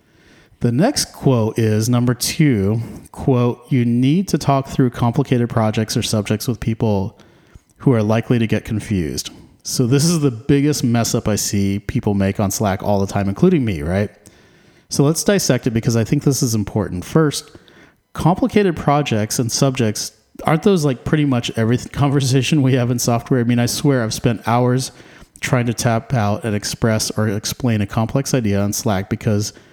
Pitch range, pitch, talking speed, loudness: 110-140 Hz, 120 Hz, 180 wpm, -18 LUFS